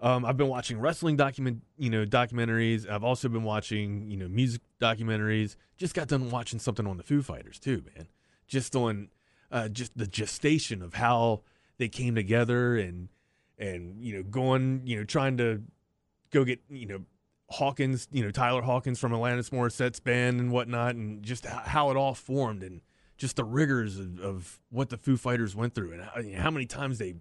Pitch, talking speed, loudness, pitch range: 120 Hz, 195 wpm, -30 LUFS, 105-130 Hz